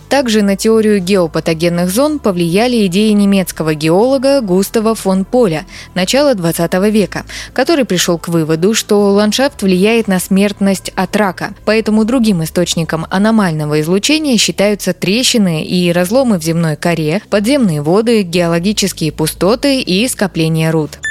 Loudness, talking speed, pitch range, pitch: -12 LUFS, 130 wpm, 175-220 Hz, 195 Hz